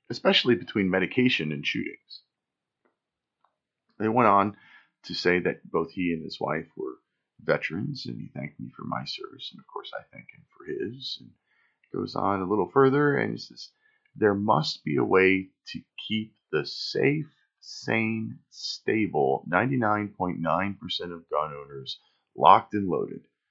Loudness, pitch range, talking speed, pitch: -26 LUFS, 90-130 Hz, 155 wpm, 105 Hz